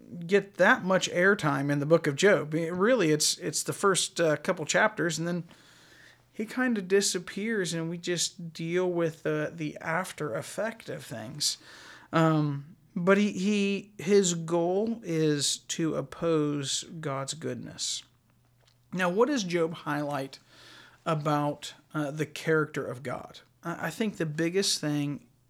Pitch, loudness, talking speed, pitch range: 165 Hz, -28 LUFS, 150 wpm, 150-190 Hz